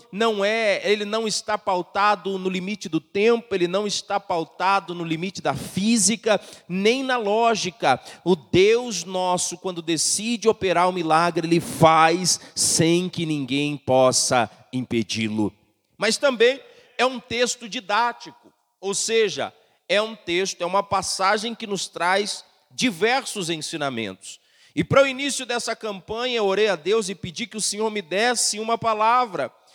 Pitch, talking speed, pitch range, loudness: 200 Hz, 150 wpm, 175-225 Hz, -22 LUFS